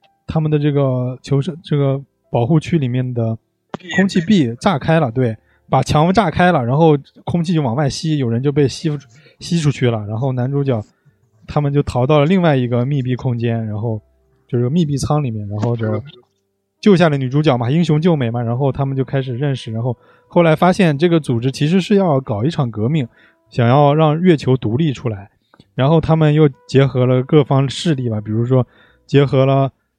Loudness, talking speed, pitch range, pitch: -16 LUFS, 290 characters per minute, 120-155 Hz, 135 Hz